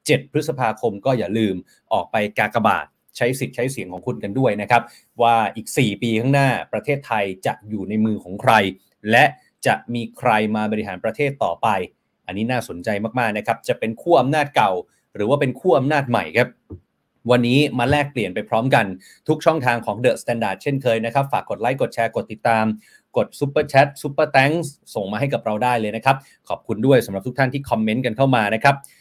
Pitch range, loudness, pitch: 110-140 Hz, -20 LUFS, 120 Hz